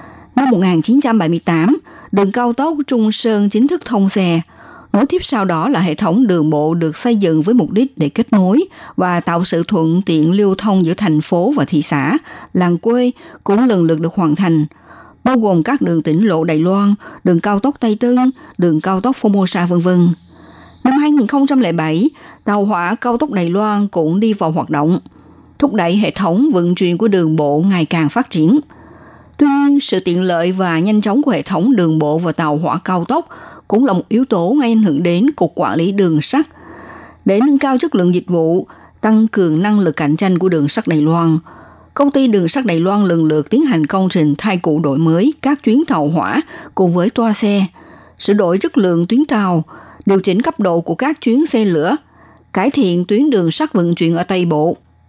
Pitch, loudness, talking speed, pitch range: 195 Hz, -14 LUFS, 210 wpm, 170-245 Hz